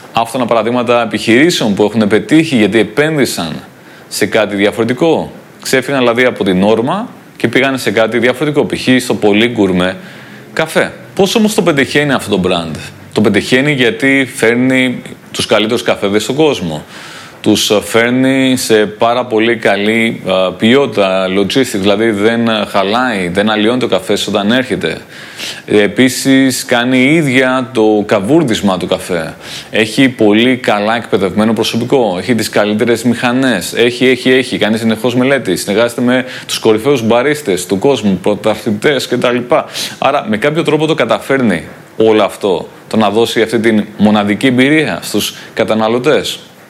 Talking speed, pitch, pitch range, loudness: 140 wpm, 115 Hz, 105-130 Hz, -11 LUFS